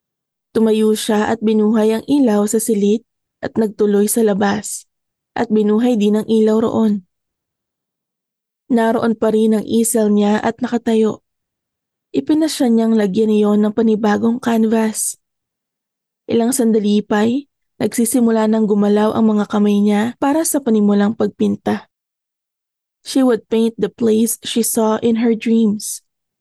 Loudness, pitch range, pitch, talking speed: -16 LUFS, 210-230 Hz, 220 Hz, 130 wpm